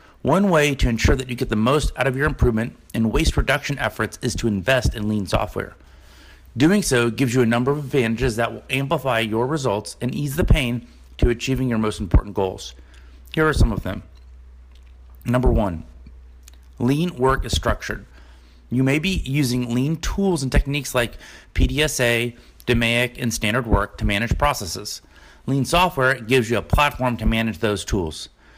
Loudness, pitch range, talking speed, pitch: -21 LUFS, 100-130 Hz, 175 wpm, 120 Hz